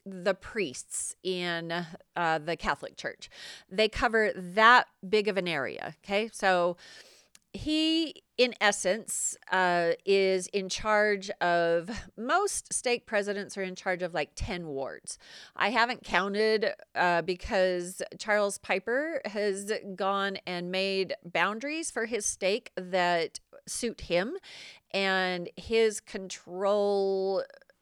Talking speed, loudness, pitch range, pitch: 115 wpm, -29 LUFS, 180-215 Hz, 195 Hz